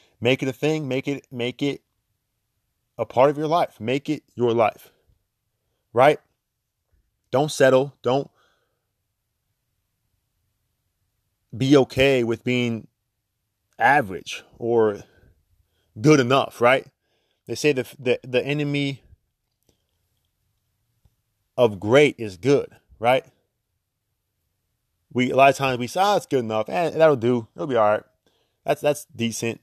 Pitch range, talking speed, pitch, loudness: 105-130 Hz, 125 wpm, 115 Hz, -21 LUFS